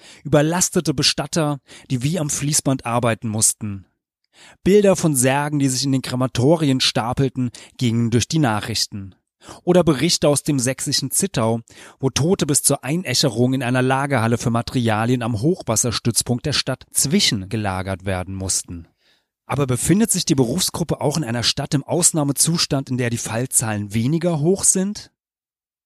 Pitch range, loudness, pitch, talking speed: 115-155 Hz, -19 LUFS, 135 Hz, 145 wpm